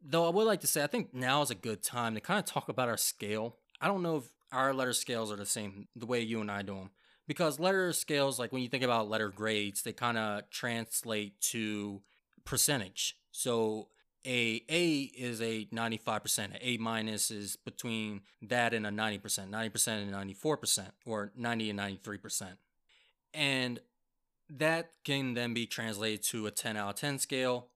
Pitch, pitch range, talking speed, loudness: 115 Hz, 105-130 Hz, 190 wpm, -34 LUFS